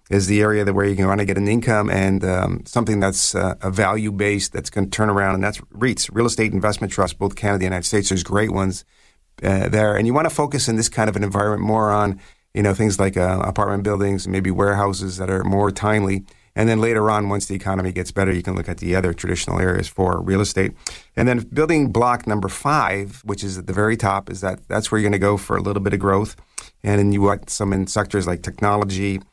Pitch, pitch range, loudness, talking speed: 100 Hz, 95-105 Hz, -20 LUFS, 255 wpm